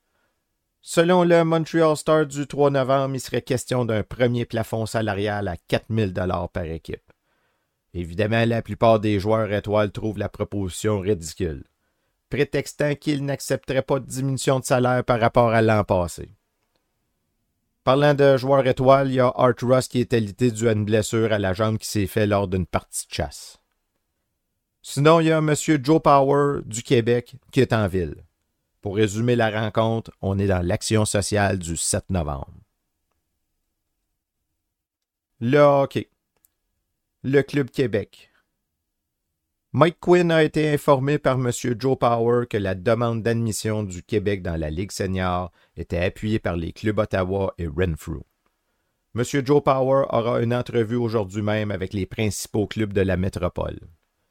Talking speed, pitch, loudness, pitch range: 155 wpm, 110 Hz, -22 LUFS, 95-130 Hz